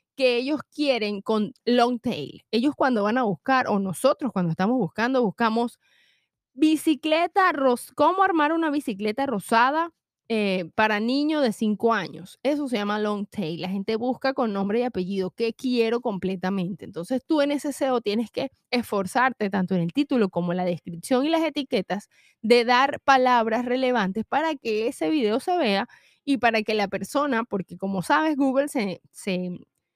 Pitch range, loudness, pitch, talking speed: 200-270 Hz, -24 LUFS, 235 Hz, 170 wpm